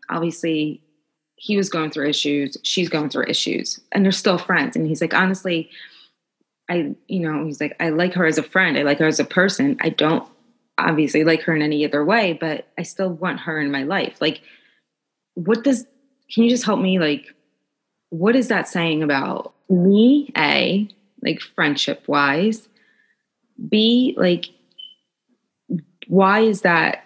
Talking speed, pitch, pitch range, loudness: 170 wpm, 180 Hz, 155-215 Hz, -19 LUFS